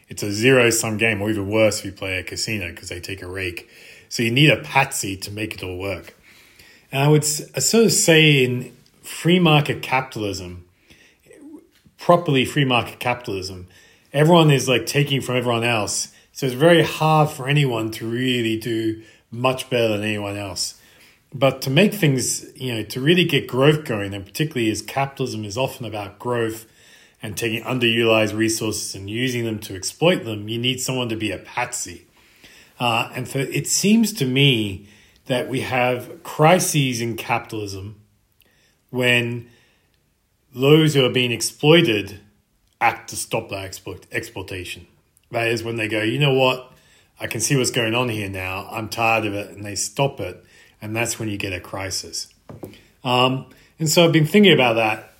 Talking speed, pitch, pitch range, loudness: 175 wpm, 115 Hz, 105-135 Hz, -20 LUFS